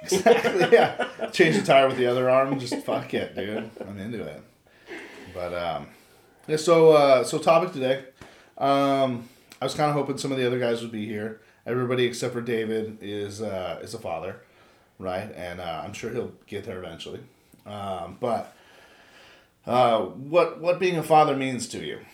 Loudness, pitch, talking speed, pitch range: -24 LUFS, 130 Hz, 180 wpm, 110-145 Hz